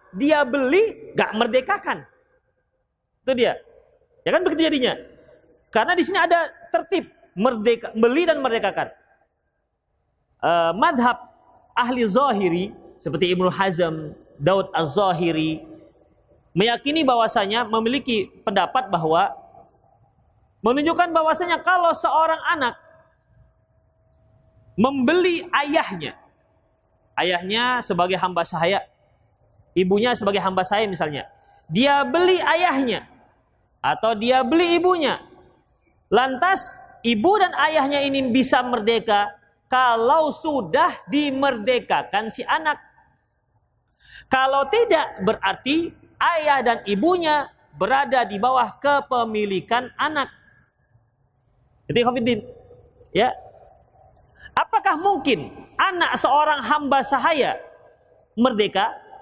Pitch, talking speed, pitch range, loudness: 250 Hz, 90 wpm, 190-320 Hz, -21 LUFS